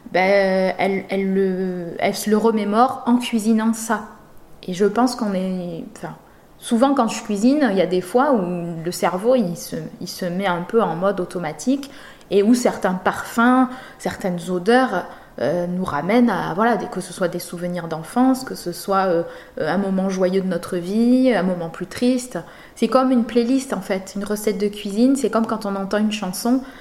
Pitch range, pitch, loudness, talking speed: 185-240 Hz, 200 Hz, -20 LUFS, 195 wpm